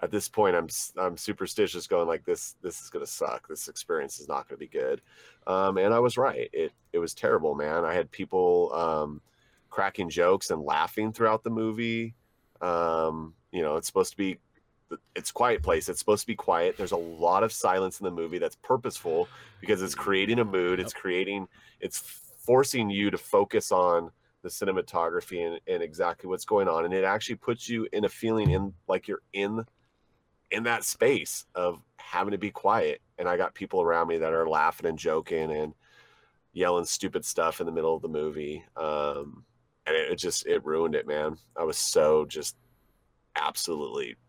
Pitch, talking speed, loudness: 120 Hz, 195 wpm, -28 LUFS